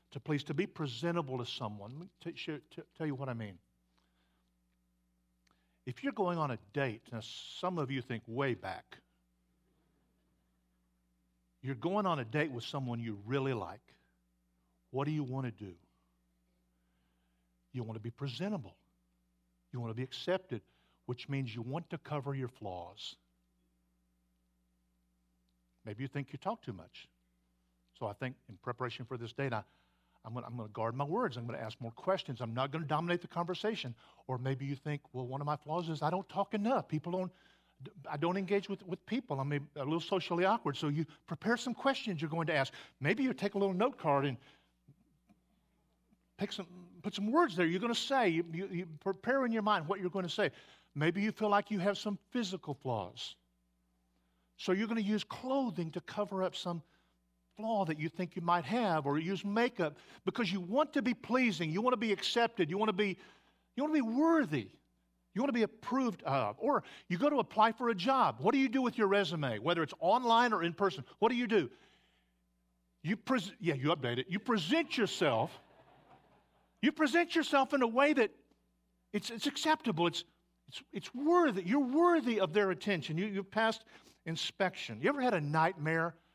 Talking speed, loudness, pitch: 190 wpm, -35 LUFS, 155 Hz